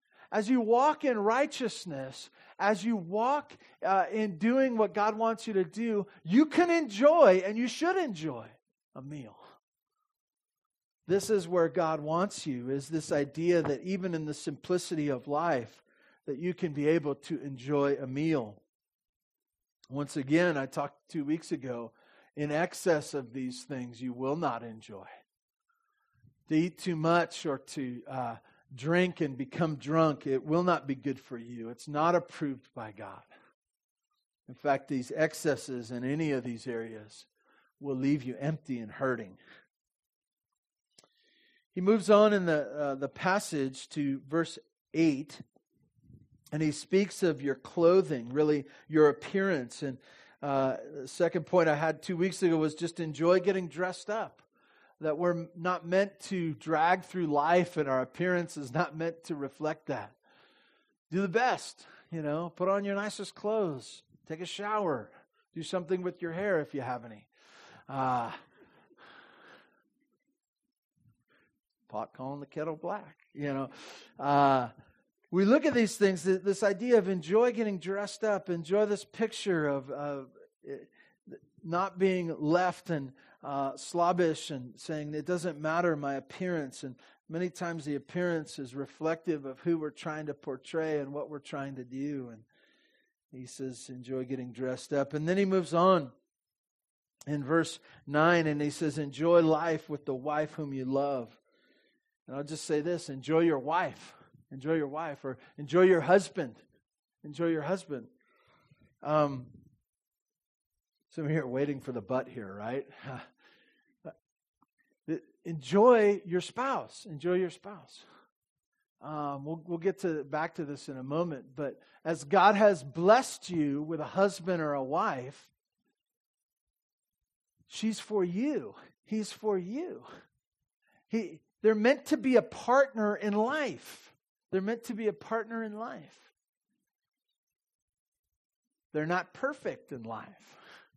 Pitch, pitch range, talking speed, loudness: 165 Hz, 140-195 Hz, 150 wpm, -31 LUFS